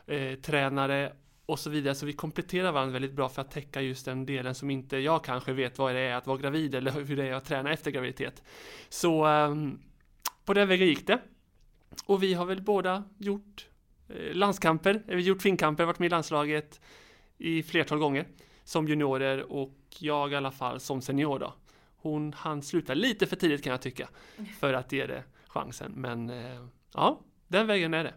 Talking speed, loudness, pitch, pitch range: 195 wpm, -30 LUFS, 145 Hz, 135-170 Hz